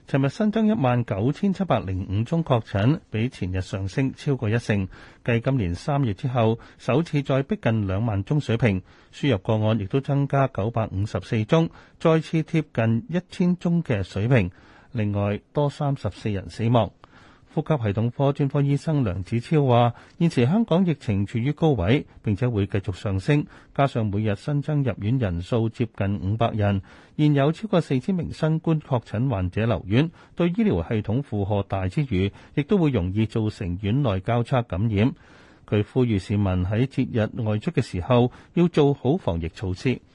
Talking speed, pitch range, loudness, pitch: 265 characters per minute, 105-145 Hz, -24 LUFS, 120 Hz